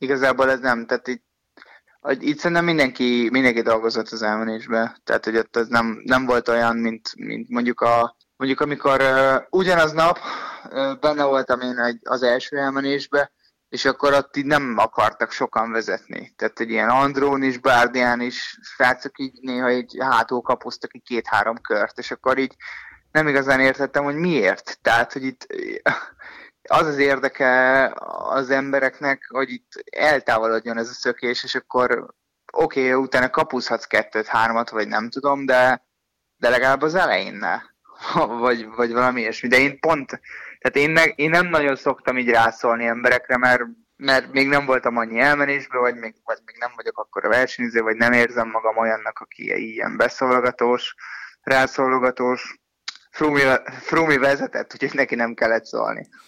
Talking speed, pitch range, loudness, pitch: 160 wpm, 120-140 Hz, -20 LUFS, 130 Hz